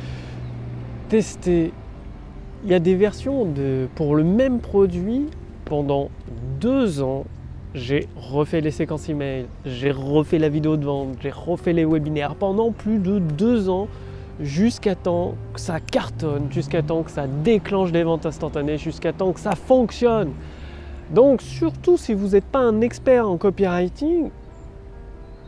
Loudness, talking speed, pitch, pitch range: -21 LUFS, 145 wpm, 160 Hz, 135-200 Hz